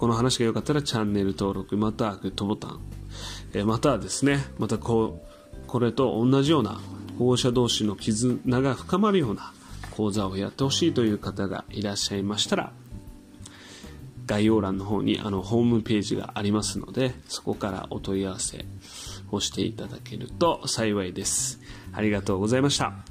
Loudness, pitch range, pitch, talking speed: -26 LUFS, 100-125 Hz, 105 Hz, 350 characters per minute